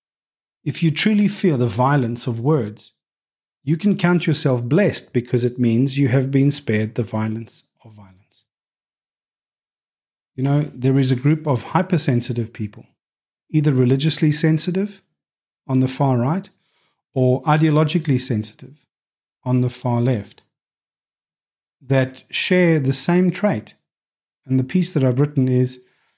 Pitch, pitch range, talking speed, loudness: 135 Hz, 125-155 Hz, 135 wpm, -19 LUFS